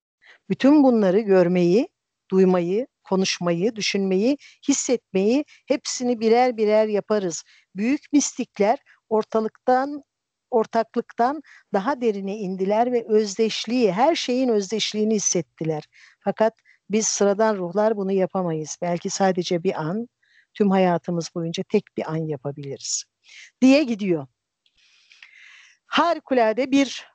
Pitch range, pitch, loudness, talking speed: 185-245 Hz, 215 Hz, -22 LUFS, 100 wpm